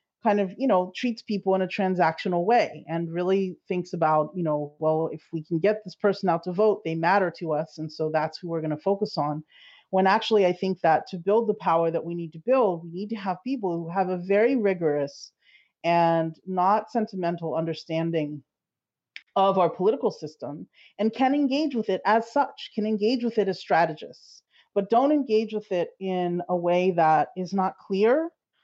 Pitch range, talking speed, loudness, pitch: 165-210 Hz, 200 wpm, -25 LUFS, 185 Hz